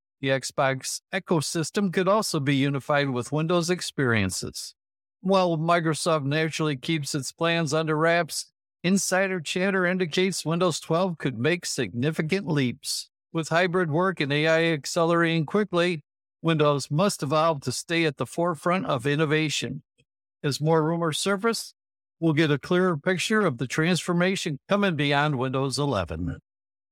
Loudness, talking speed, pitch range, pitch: -25 LUFS, 135 wpm, 140-180 Hz, 160 Hz